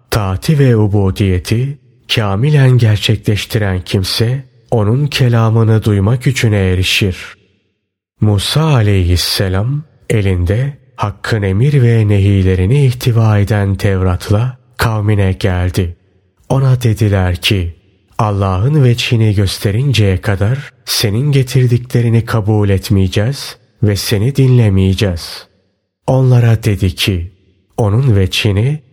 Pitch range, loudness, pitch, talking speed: 95-125 Hz, -13 LUFS, 105 Hz, 85 wpm